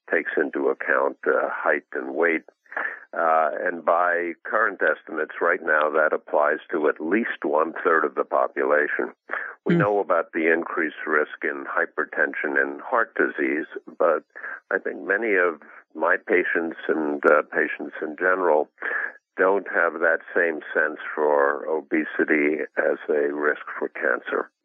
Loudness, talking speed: -23 LUFS, 140 wpm